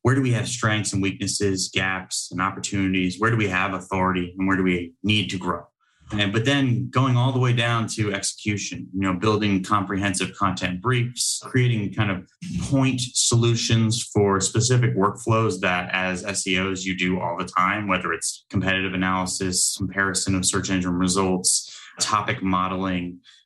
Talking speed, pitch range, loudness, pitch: 165 wpm, 95-110 Hz, -22 LUFS, 95 Hz